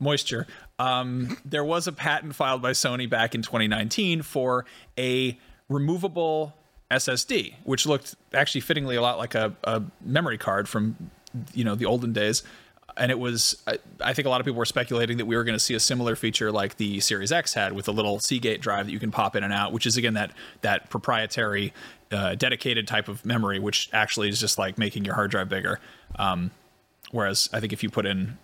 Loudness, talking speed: -25 LUFS, 210 wpm